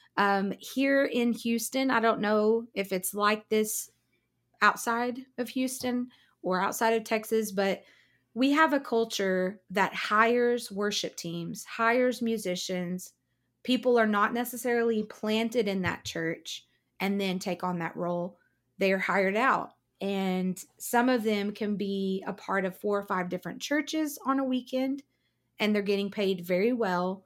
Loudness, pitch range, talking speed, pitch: -29 LUFS, 190-240 Hz, 155 wpm, 210 Hz